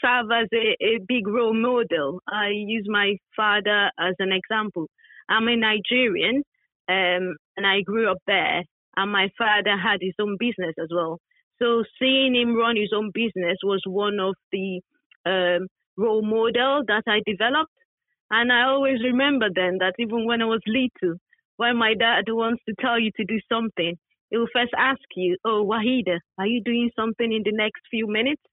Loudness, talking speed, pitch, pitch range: -22 LUFS, 180 wpm, 220 Hz, 195-235 Hz